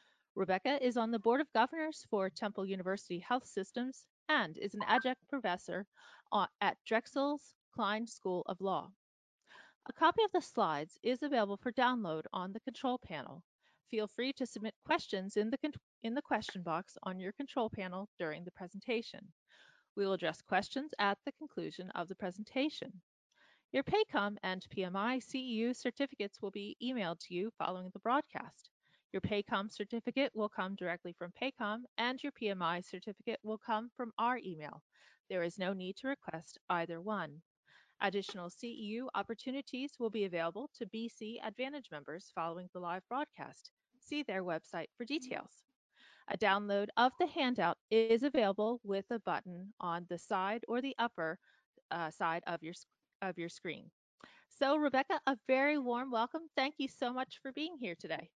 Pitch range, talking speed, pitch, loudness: 185-255 Hz, 165 wpm, 220 Hz, -38 LUFS